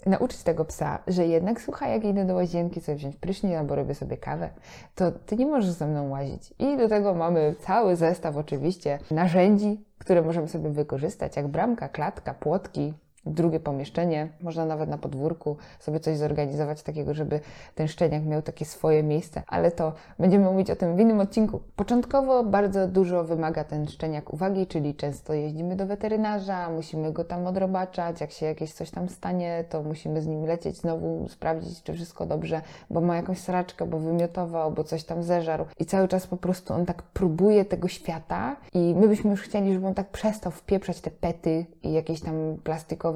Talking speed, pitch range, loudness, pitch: 185 wpm, 155-190 Hz, -27 LUFS, 170 Hz